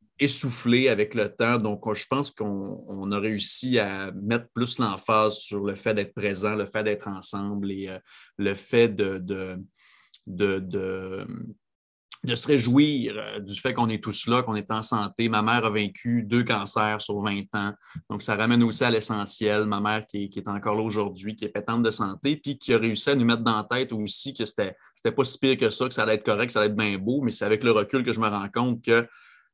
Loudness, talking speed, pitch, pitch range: -25 LUFS, 235 wpm, 110 Hz, 100-120 Hz